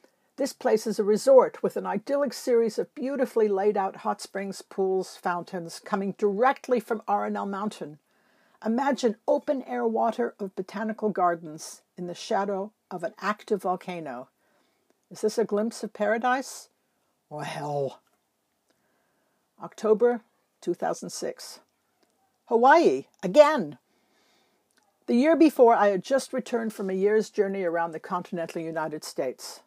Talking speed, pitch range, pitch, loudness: 130 wpm, 185-250 Hz, 215 Hz, -26 LUFS